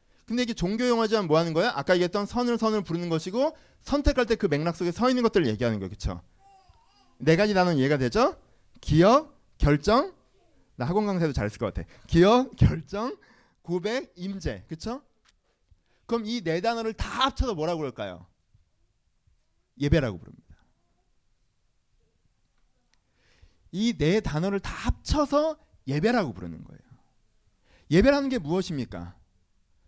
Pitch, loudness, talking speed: 175 Hz, -26 LUFS, 295 characters per minute